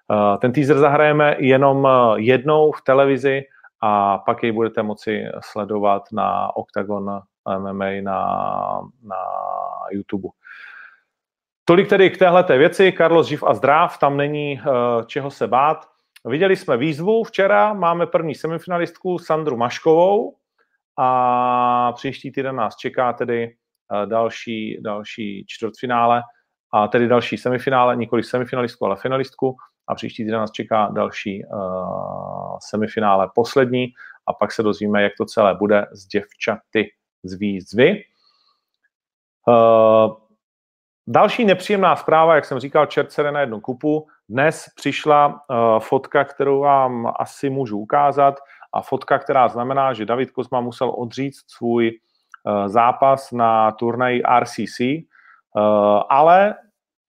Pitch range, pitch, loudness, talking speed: 110-145 Hz, 125 Hz, -18 LUFS, 125 wpm